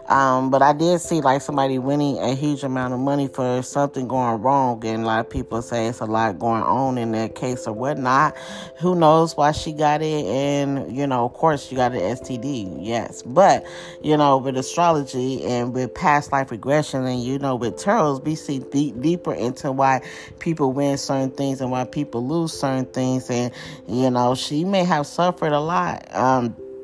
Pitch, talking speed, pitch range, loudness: 135 Hz, 200 wpm, 125-145 Hz, -21 LUFS